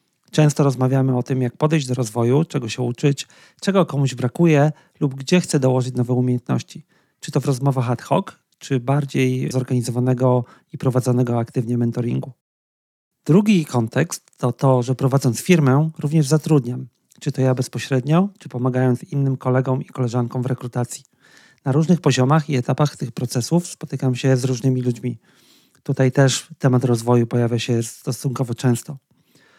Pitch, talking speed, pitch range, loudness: 130 Hz, 150 wpm, 125-150 Hz, -20 LUFS